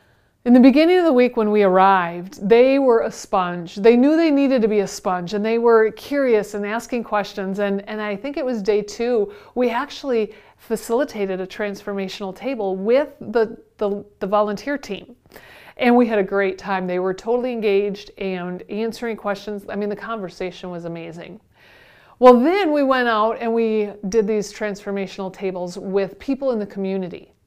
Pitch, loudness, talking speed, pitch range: 210 Hz, -20 LUFS, 180 wpm, 195-240 Hz